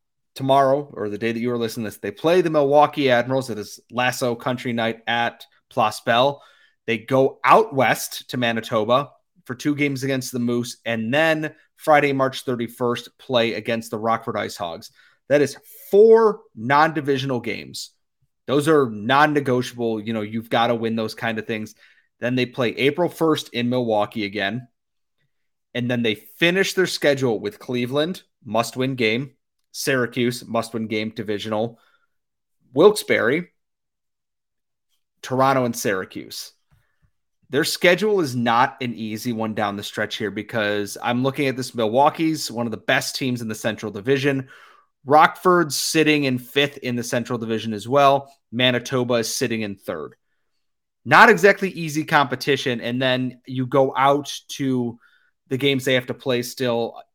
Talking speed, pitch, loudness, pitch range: 155 wpm, 125 Hz, -21 LUFS, 115-140 Hz